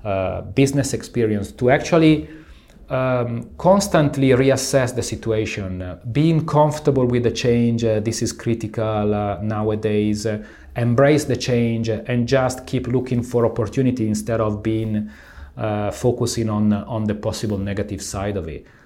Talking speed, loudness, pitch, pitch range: 140 wpm, -20 LUFS, 115 Hz, 105-130 Hz